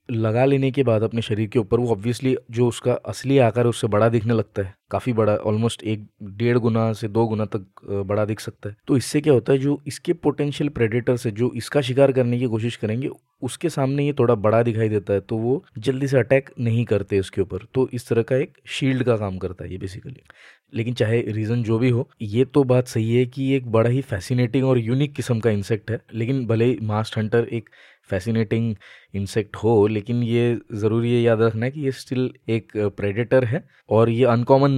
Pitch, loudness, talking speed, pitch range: 120 Hz, -22 LUFS, 215 wpm, 110-130 Hz